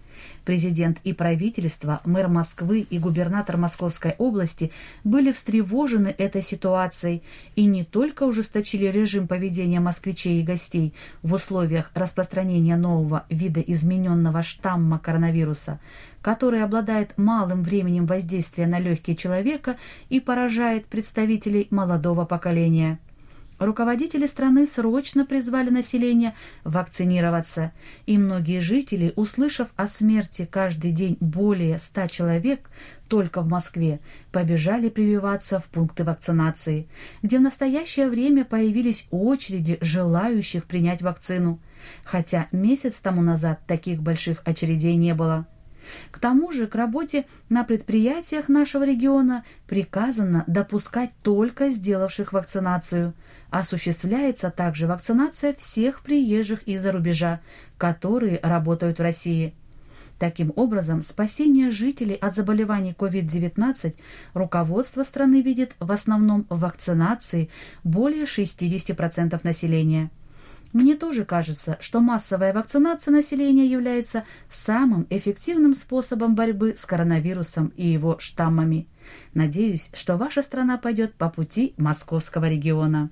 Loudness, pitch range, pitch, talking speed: -23 LUFS, 170-230 Hz, 185 Hz, 110 wpm